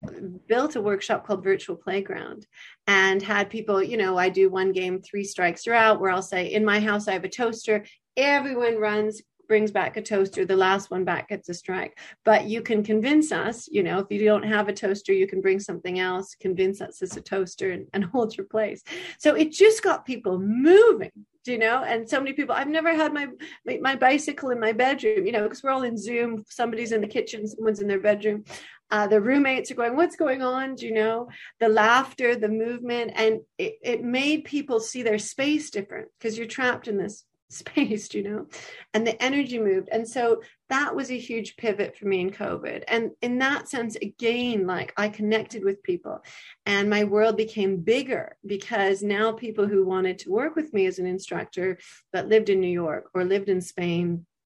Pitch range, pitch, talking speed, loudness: 195-245 Hz, 215 Hz, 210 wpm, -24 LUFS